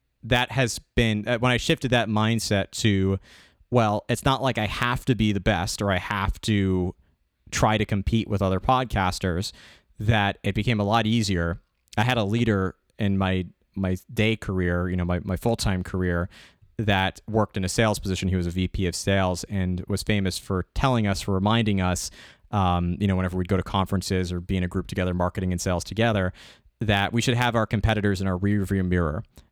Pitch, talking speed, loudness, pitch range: 100 Hz, 205 wpm, -25 LUFS, 90-110 Hz